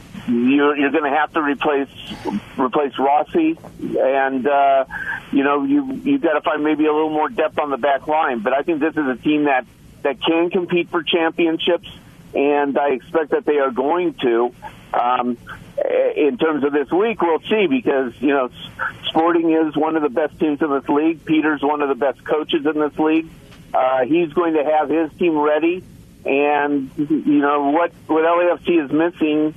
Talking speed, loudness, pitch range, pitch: 190 wpm, -19 LUFS, 145-170 Hz, 155 Hz